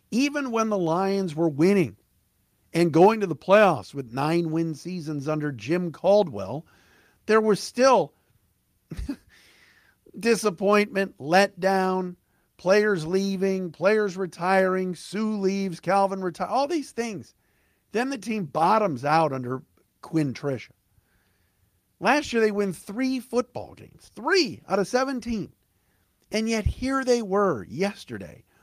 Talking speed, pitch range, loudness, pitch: 120 wpm, 155-215 Hz, -24 LUFS, 190 Hz